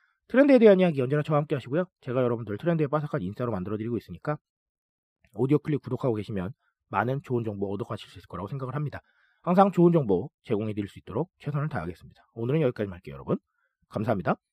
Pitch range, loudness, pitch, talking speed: 105-150 Hz, -27 LUFS, 130 Hz, 505 characters per minute